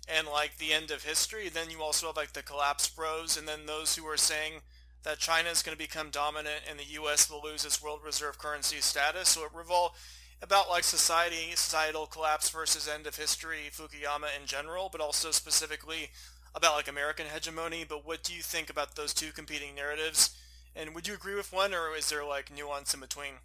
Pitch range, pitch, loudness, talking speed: 150-160 Hz, 155 Hz, -31 LUFS, 210 wpm